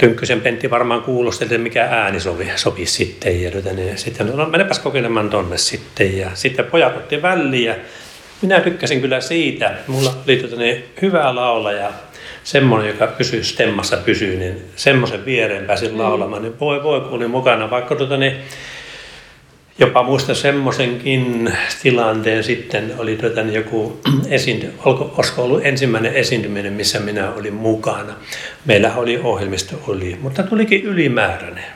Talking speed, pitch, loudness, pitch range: 140 wpm, 120 Hz, -17 LUFS, 110-135 Hz